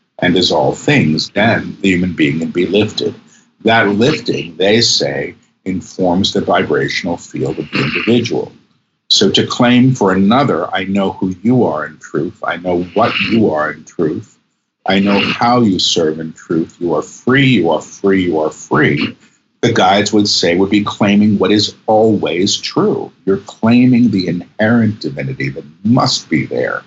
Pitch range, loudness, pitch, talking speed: 90-110 Hz, -13 LUFS, 100 Hz, 170 wpm